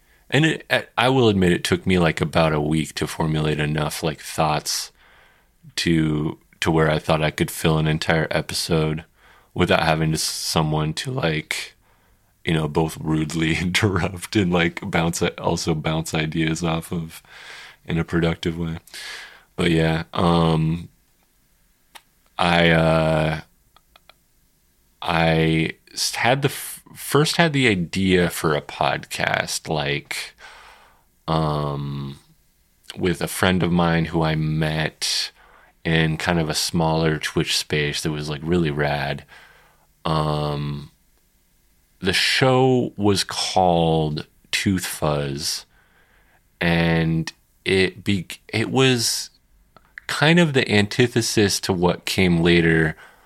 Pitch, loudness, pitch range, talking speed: 80 Hz, -21 LUFS, 80-90 Hz, 125 wpm